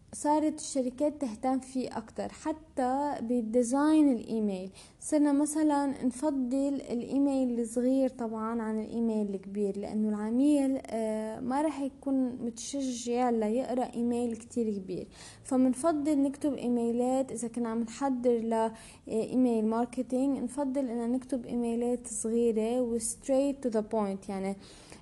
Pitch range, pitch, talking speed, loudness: 225-275 Hz, 245 Hz, 115 wpm, -31 LUFS